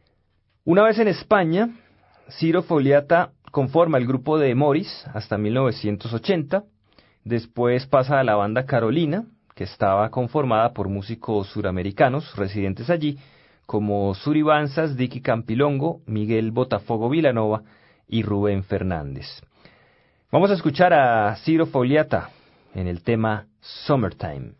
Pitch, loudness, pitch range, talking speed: 125 Hz, -22 LUFS, 105-155 Hz, 115 wpm